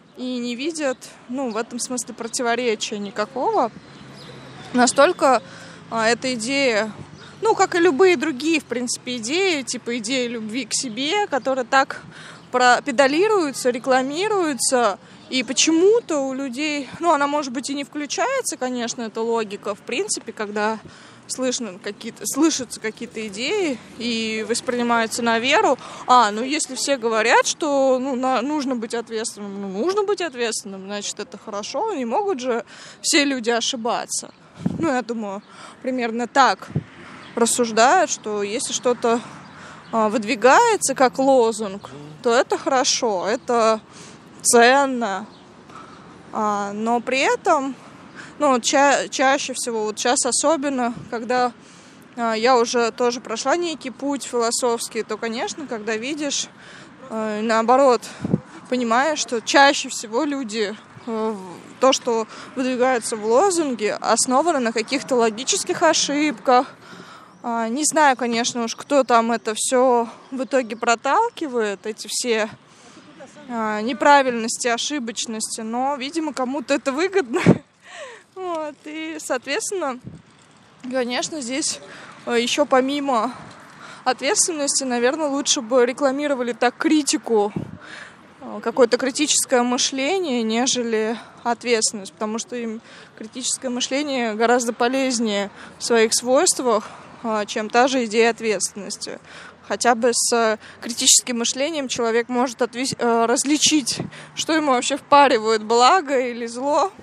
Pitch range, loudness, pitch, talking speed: 230-280 Hz, -20 LUFS, 250 Hz, 115 wpm